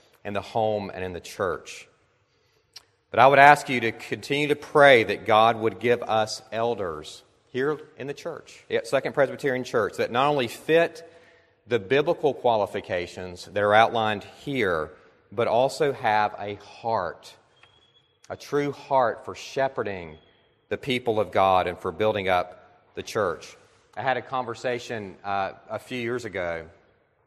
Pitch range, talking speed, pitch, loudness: 100-140 Hz, 155 wpm, 115 Hz, -24 LUFS